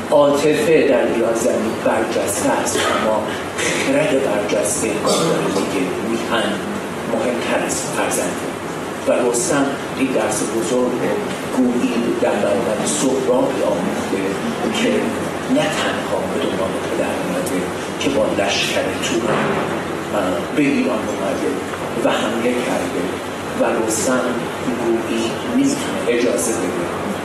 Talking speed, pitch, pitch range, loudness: 110 wpm, 125 Hz, 115-150 Hz, -19 LUFS